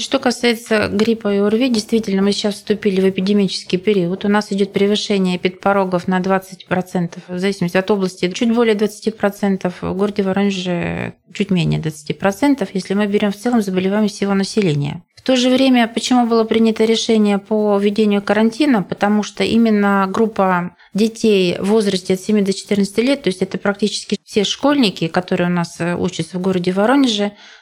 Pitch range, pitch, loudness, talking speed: 185-220 Hz, 200 Hz, -17 LUFS, 165 wpm